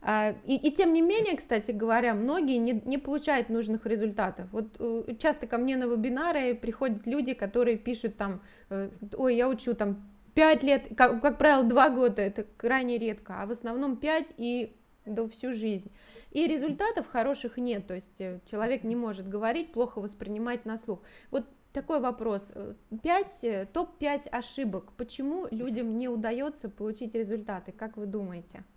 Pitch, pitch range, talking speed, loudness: 235 Hz, 220-270 Hz, 155 wpm, -30 LUFS